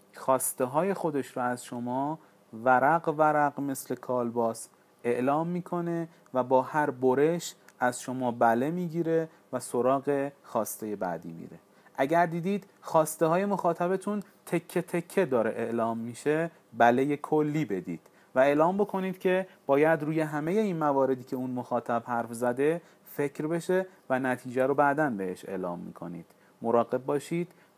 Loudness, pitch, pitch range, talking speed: -29 LUFS, 140 Hz, 125-170 Hz, 135 wpm